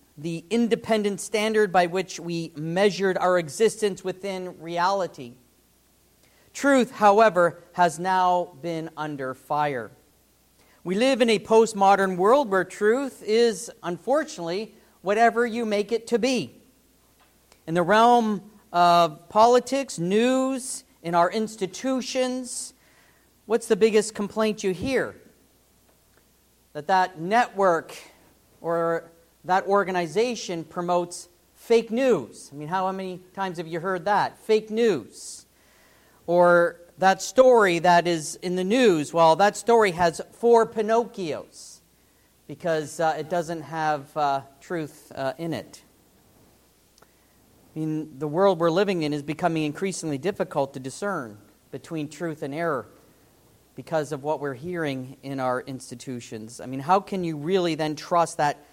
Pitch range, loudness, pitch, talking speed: 155-215 Hz, -24 LUFS, 180 Hz, 130 wpm